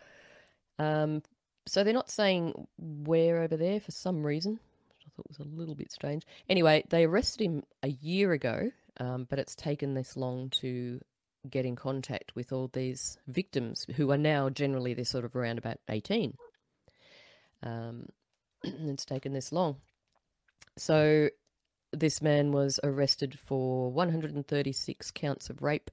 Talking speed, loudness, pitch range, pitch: 150 wpm, -31 LUFS, 130-160 Hz, 145 Hz